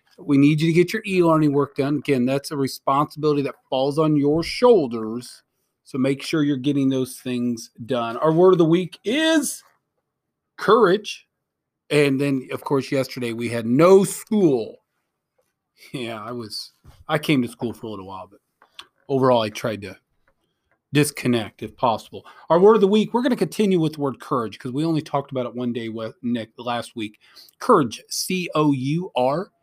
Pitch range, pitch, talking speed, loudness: 120-160 Hz, 140 Hz, 185 wpm, -21 LUFS